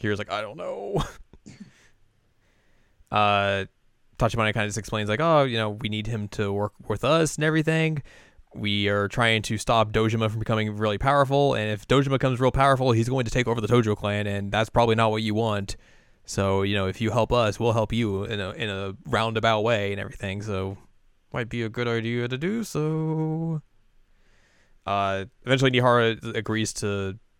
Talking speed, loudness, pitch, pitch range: 190 wpm, -24 LUFS, 110 Hz, 105-120 Hz